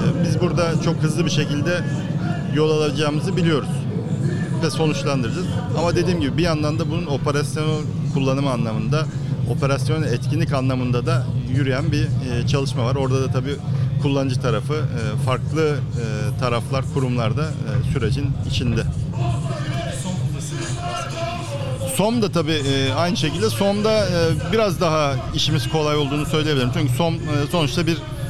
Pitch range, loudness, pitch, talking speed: 135-155 Hz, -21 LUFS, 145 Hz, 120 wpm